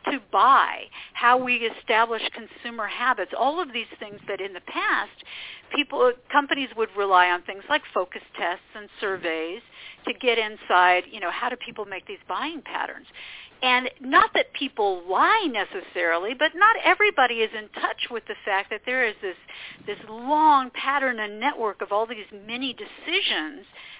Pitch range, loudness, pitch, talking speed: 205-270 Hz, -23 LUFS, 225 Hz, 170 wpm